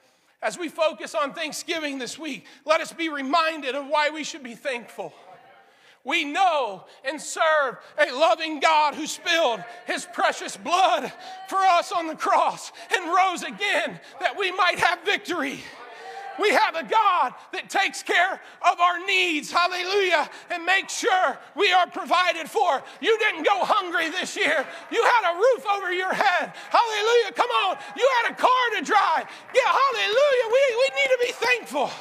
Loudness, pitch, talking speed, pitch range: -23 LUFS, 355 Hz, 170 wpm, 315-400 Hz